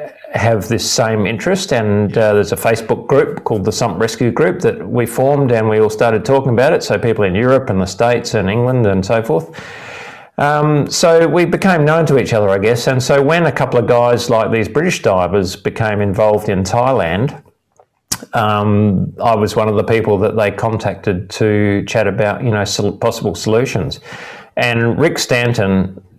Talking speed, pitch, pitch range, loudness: 190 wpm, 115 Hz, 105-125 Hz, -14 LUFS